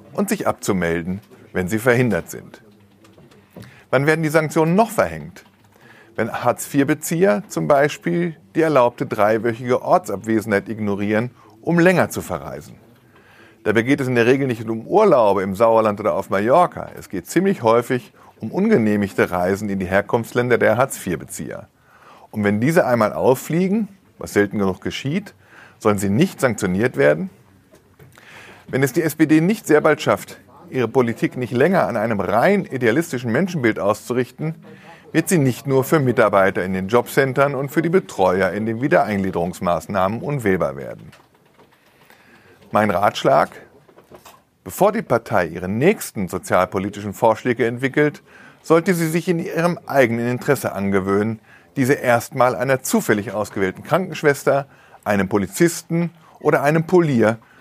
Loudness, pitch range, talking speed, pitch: -19 LUFS, 105-160 Hz, 135 wpm, 125 Hz